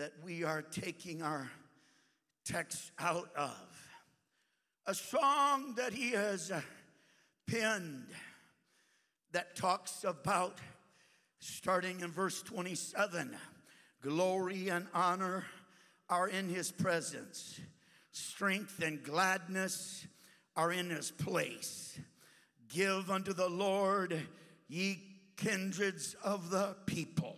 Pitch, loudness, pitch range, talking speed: 185 Hz, -37 LUFS, 170-195 Hz, 95 wpm